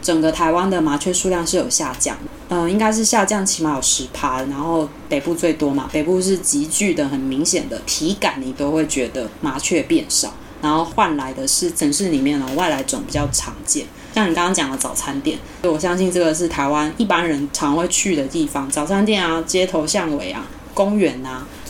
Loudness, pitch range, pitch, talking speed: -19 LUFS, 150-195 Hz, 170 Hz, 305 characters per minute